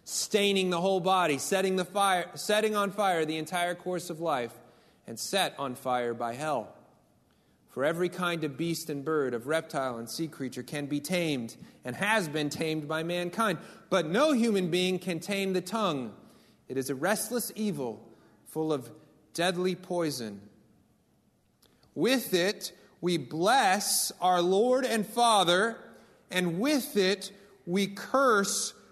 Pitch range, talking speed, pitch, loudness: 150-195 Hz, 150 wpm, 175 Hz, -29 LUFS